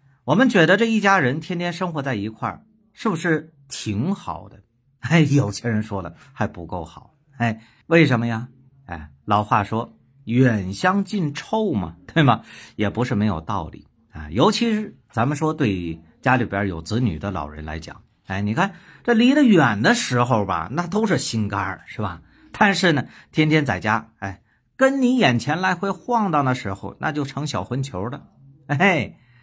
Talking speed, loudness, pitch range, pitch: 245 characters per minute, -21 LUFS, 105-170 Hz, 130 Hz